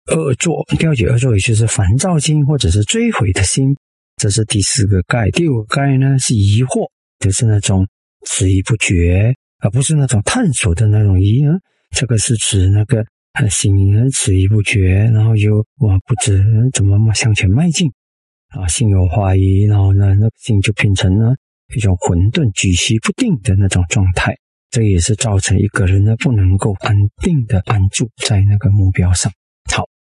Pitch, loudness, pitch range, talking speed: 105 Hz, -14 LUFS, 95-125 Hz, 255 characters per minute